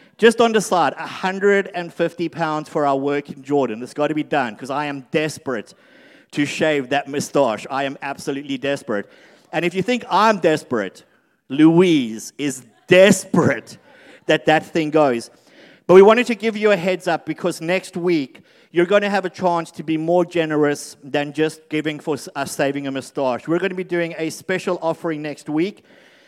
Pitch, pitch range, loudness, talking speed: 160 Hz, 145-180 Hz, -19 LUFS, 185 wpm